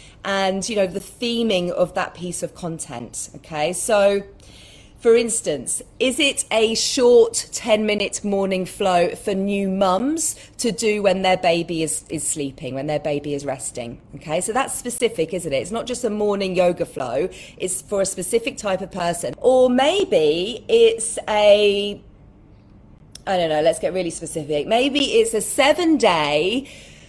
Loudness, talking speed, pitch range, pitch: -20 LUFS, 165 wpm, 160-225 Hz, 195 Hz